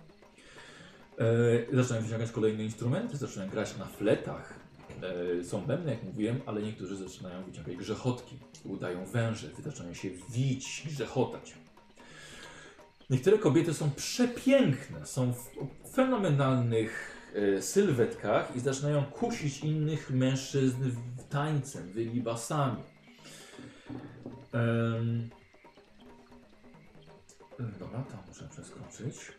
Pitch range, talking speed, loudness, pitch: 115-140 Hz, 85 wpm, -32 LUFS, 125 Hz